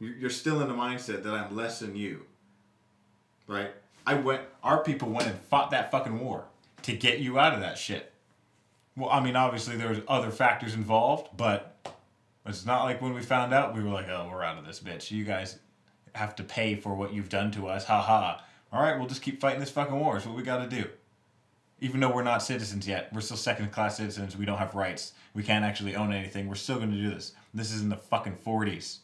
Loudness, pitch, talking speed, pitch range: -30 LUFS, 110 Hz, 235 wpm, 100-125 Hz